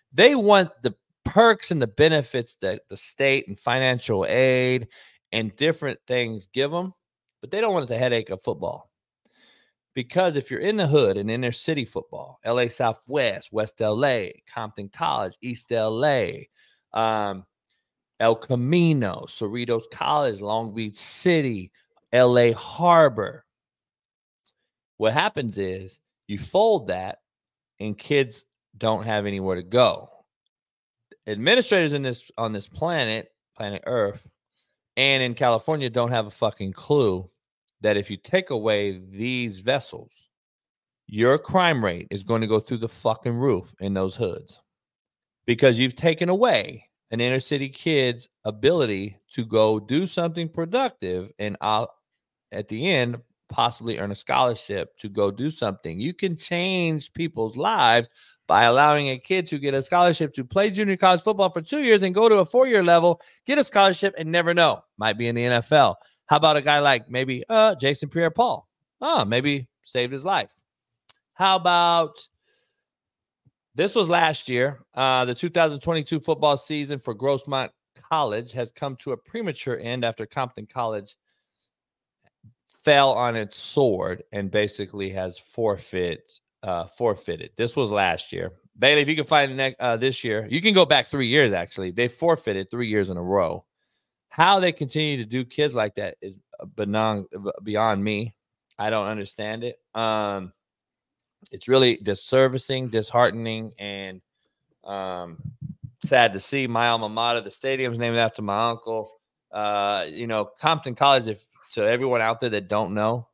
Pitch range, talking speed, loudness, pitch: 110-150 Hz, 155 wpm, -22 LUFS, 125 Hz